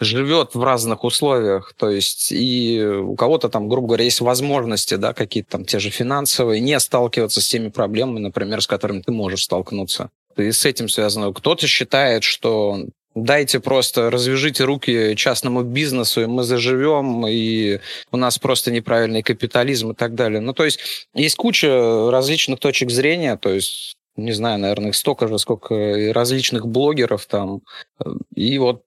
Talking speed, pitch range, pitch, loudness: 165 wpm, 110-130 Hz, 120 Hz, -18 LUFS